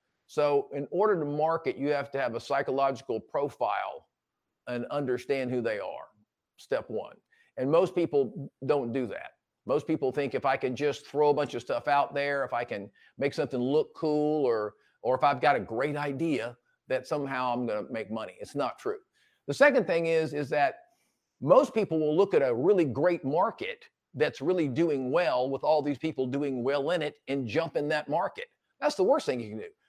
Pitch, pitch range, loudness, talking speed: 145 Hz, 135-175 Hz, -29 LUFS, 205 wpm